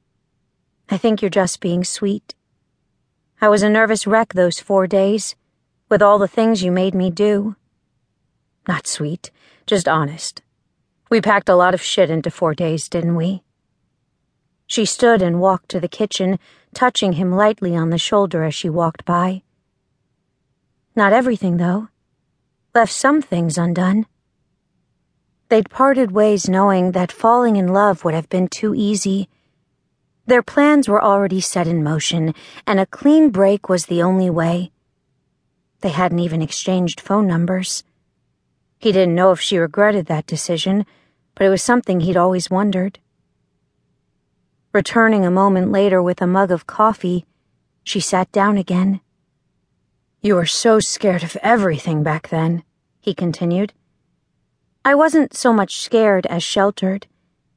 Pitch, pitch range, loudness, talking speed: 190 Hz, 175-210 Hz, -17 LUFS, 145 wpm